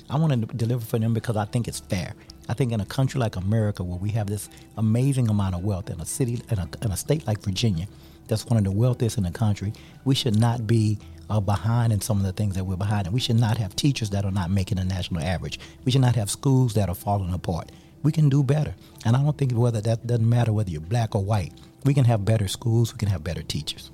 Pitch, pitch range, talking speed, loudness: 110 Hz, 100-120 Hz, 270 wpm, -25 LUFS